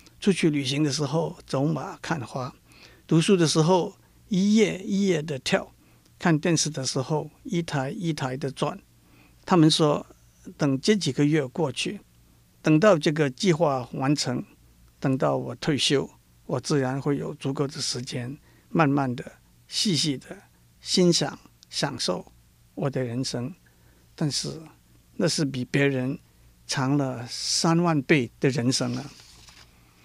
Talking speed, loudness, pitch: 195 characters per minute, -25 LUFS, 135 Hz